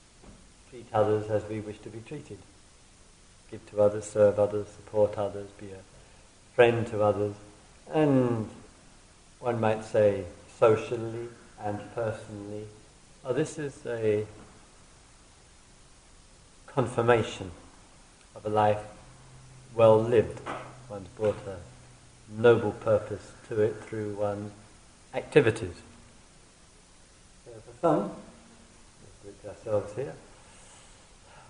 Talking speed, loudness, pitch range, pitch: 105 wpm, -28 LUFS, 100-115 Hz, 105 Hz